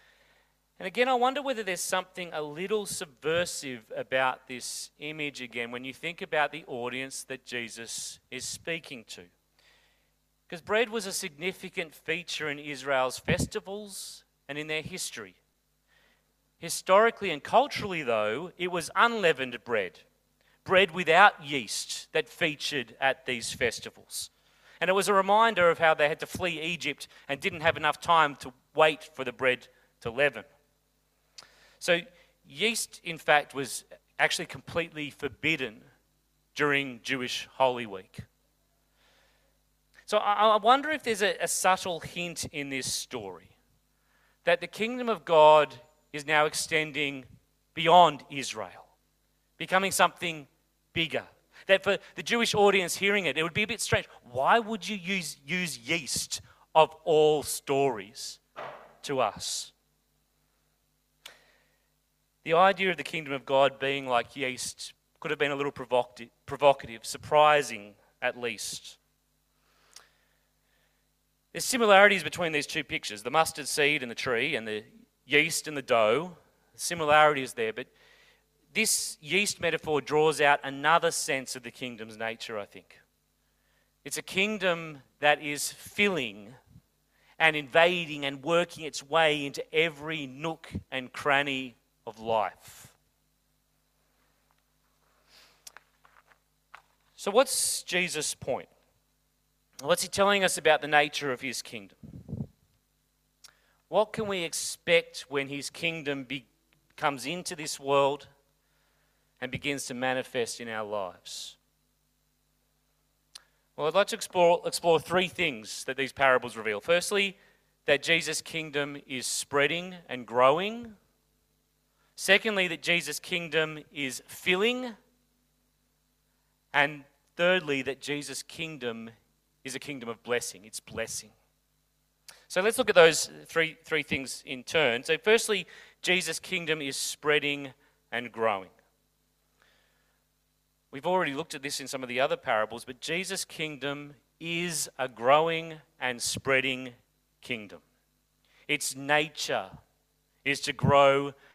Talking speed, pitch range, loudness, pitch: 130 wpm, 130-175 Hz, -28 LUFS, 150 Hz